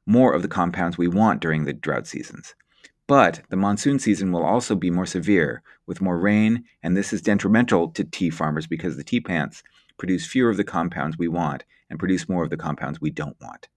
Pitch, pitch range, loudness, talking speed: 90 Hz, 85-105 Hz, -22 LUFS, 215 wpm